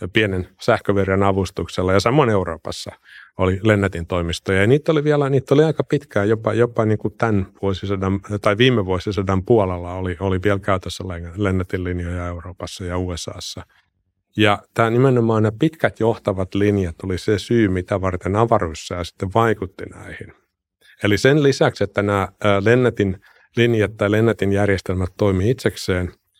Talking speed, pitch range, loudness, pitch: 145 wpm, 95-115 Hz, -19 LUFS, 100 Hz